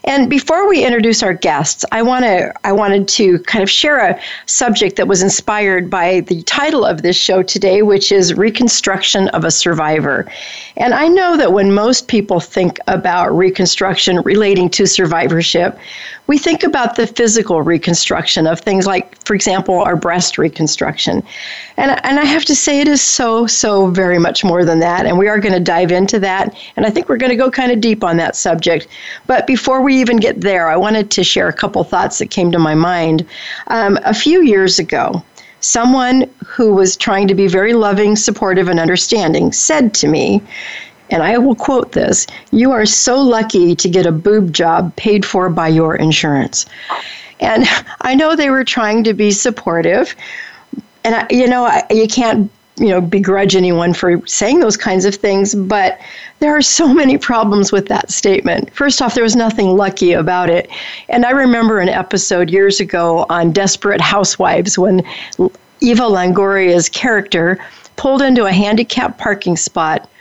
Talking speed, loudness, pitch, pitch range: 185 wpm, -12 LUFS, 200 Hz, 180-240 Hz